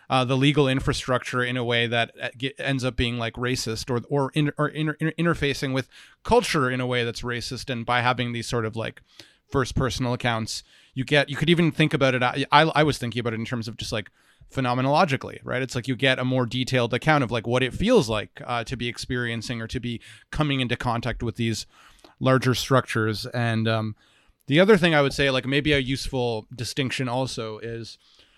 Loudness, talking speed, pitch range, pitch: -24 LUFS, 215 wpm, 120-140 Hz, 125 Hz